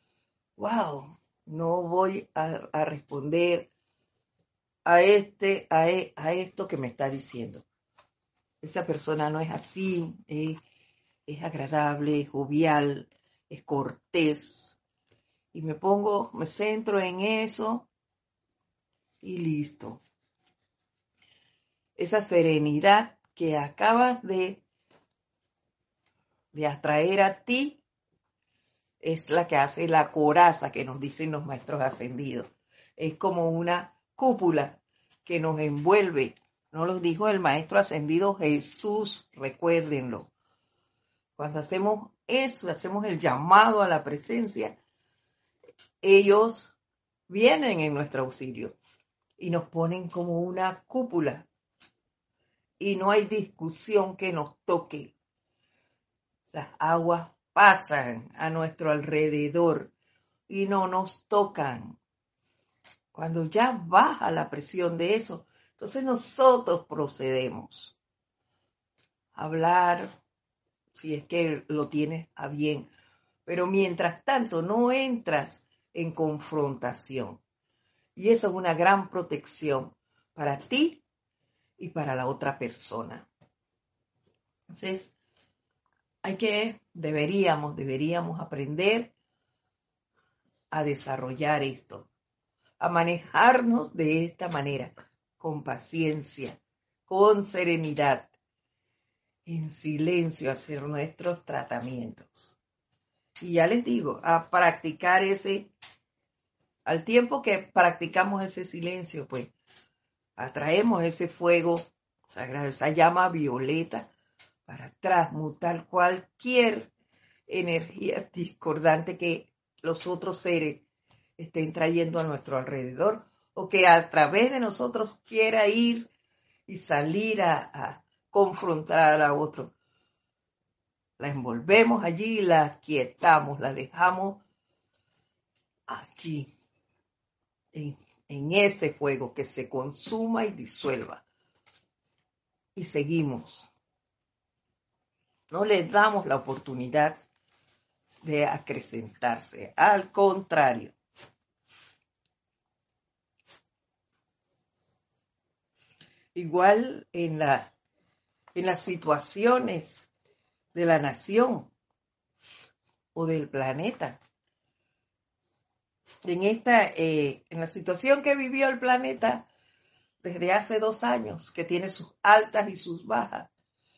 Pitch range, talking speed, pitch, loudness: 145-195 Hz, 100 wpm, 165 Hz, -26 LUFS